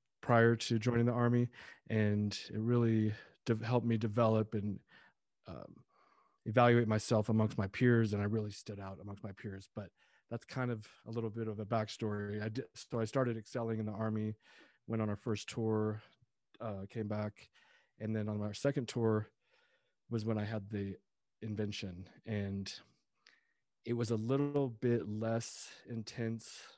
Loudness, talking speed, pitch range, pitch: -36 LUFS, 165 wpm, 105-115 Hz, 110 Hz